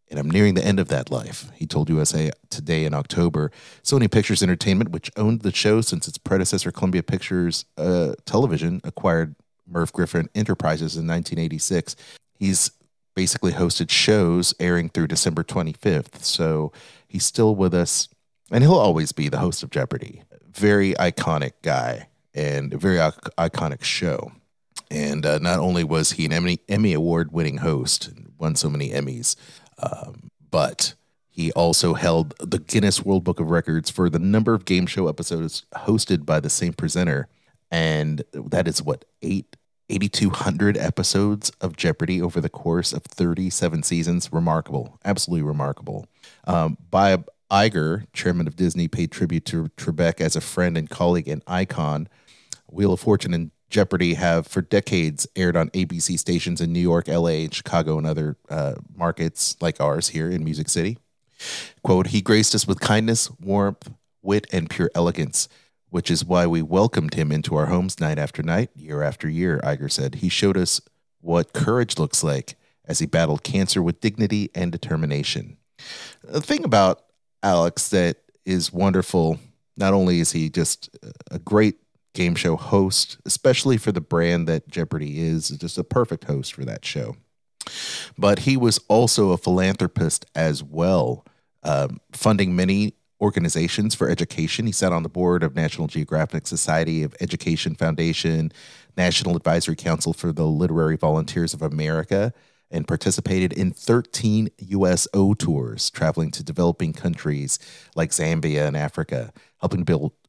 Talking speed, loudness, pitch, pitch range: 160 wpm, -22 LUFS, 85 Hz, 80-100 Hz